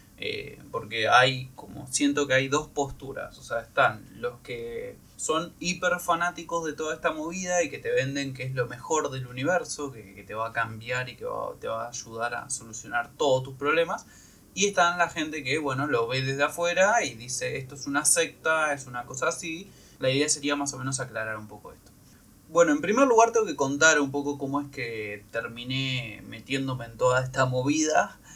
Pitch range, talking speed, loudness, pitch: 125-170 Hz, 205 wpm, -27 LUFS, 140 Hz